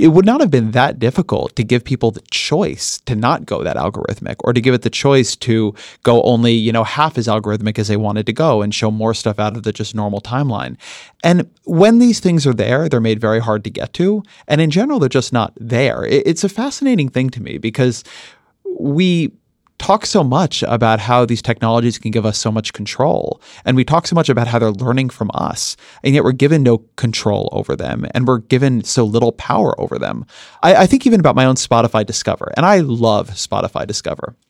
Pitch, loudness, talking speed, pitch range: 120 Hz, -15 LUFS, 225 wpm, 110-150 Hz